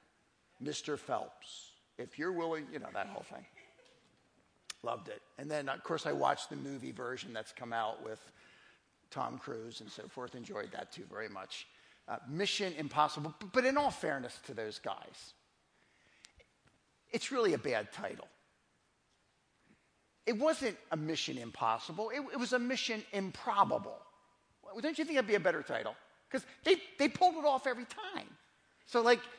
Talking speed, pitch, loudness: 165 wpm, 200 Hz, -36 LUFS